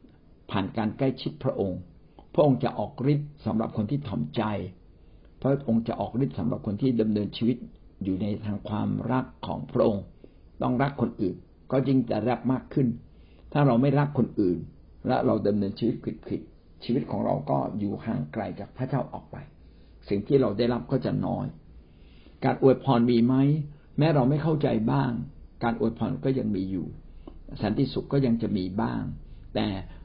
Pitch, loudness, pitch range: 115 Hz, -27 LUFS, 100-130 Hz